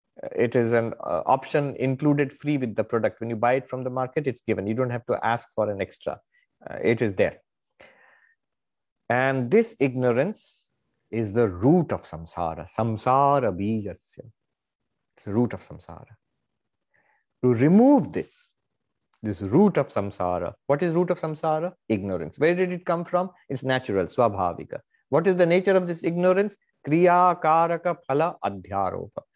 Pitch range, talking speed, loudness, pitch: 110-170 Hz, 160 wpm, -24 LUFS, 130 Hz